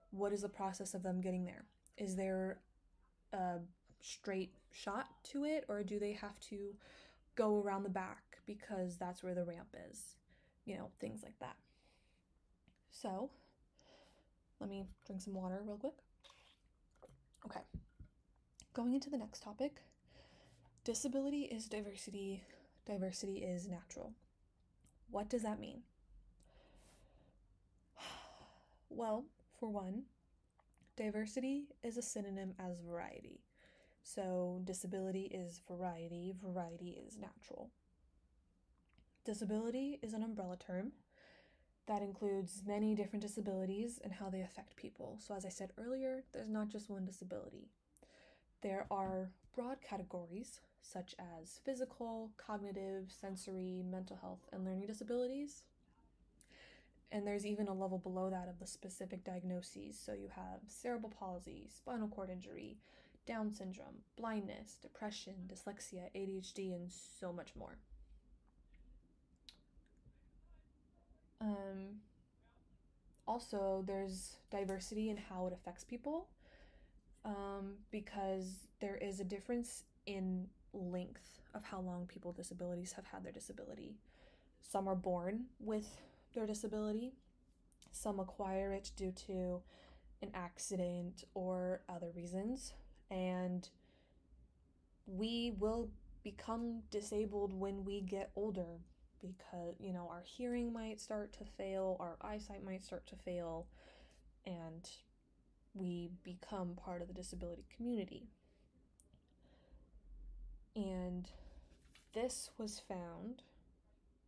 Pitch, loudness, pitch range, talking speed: 195 Hz, -46 LUFS, 180-215 Hz, 115 wpm